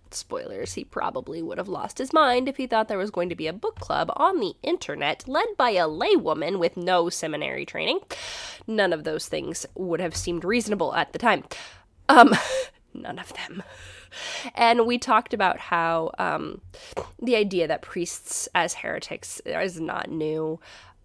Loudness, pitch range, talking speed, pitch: -24 LUFS, 170-270 Hz, 170 wpm, 205 Hz